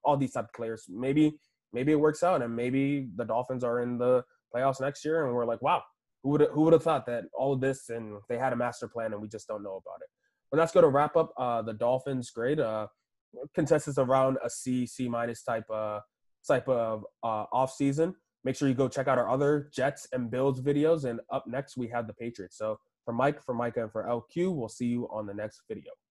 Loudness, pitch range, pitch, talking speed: -30 LUFS, 115-145 Hz, 130 Hz, 245 wpm